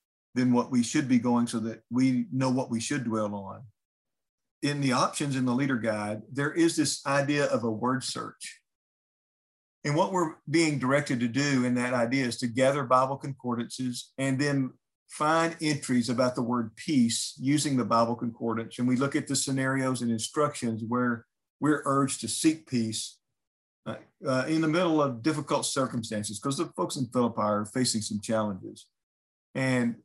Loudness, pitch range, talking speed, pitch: -28 LUFS, 115-140 Hz, 180 wpm, 125 Hz